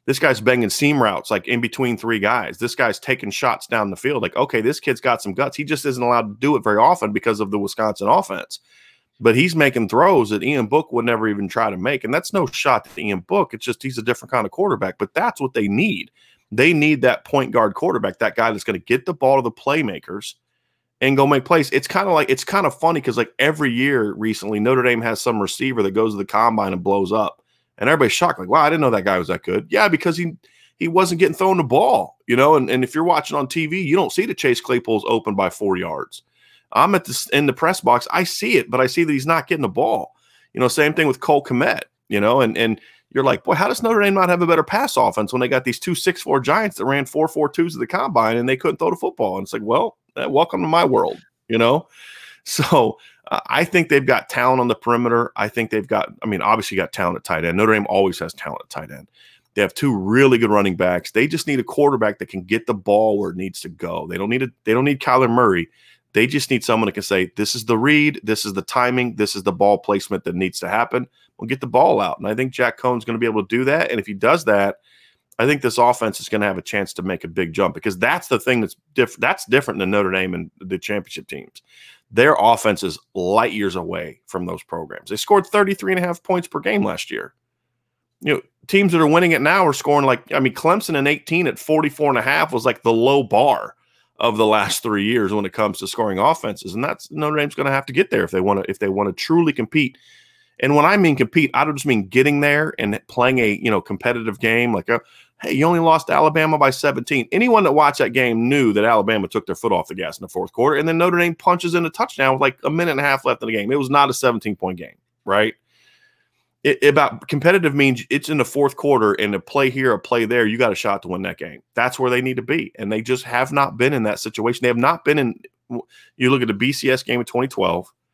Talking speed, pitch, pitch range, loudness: 265 wpm, 125 Hz, 110-150 Hz, -18 LUFS